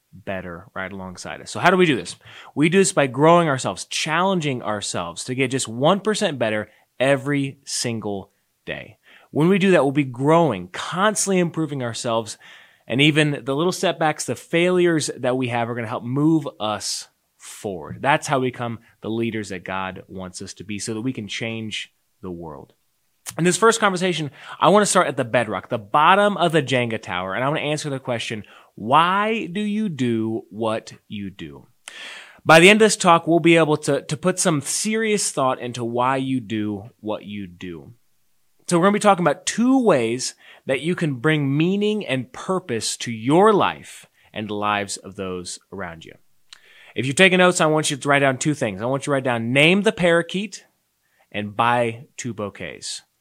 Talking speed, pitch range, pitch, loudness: 200 wpm, 110-170 Hz, 135 Hz, -20 LUFS